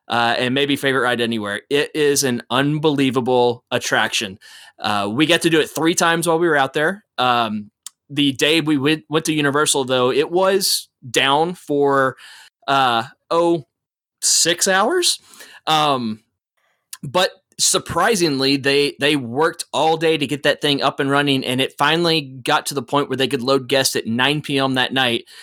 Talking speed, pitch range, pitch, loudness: 170 wpm, 130-155 Hz, 140 Hz, -18 LUFS